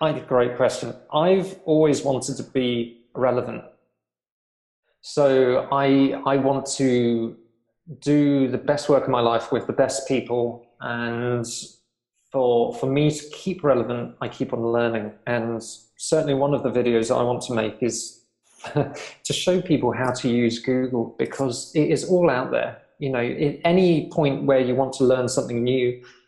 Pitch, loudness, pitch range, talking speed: 130 Hz, -22 LUFS, 120-140 Hz, 170 wpm